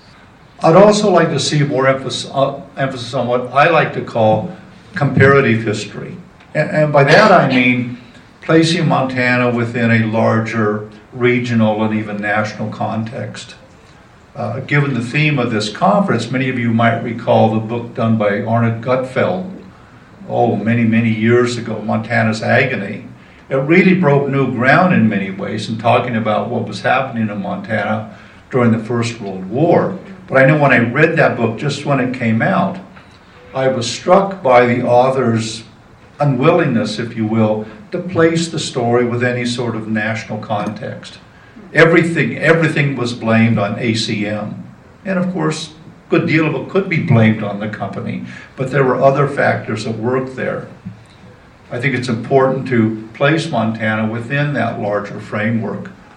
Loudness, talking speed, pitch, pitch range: -15 LUFS, 160 wpm, 120 Hz, 110-140 Hz